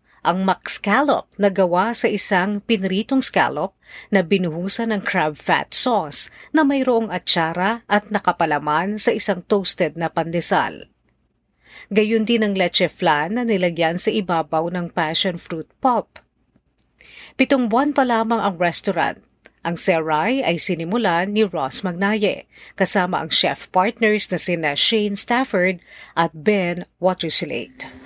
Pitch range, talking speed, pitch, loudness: 170-220 Hz, 130 wpm, 190 Hz, -19 LUFS